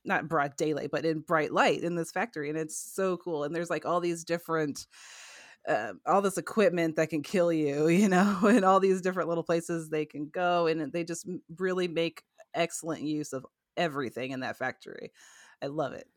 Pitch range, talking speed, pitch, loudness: 155-180 Hz, 200 wpm, 170 Hz, -29 LUFS